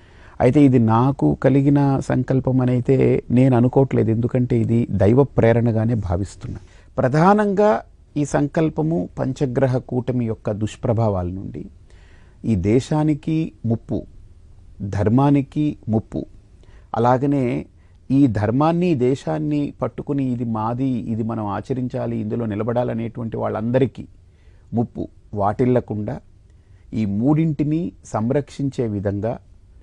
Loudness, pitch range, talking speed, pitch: -20 LUFS, 105-135 Hz, 90 wpm, 120 Hz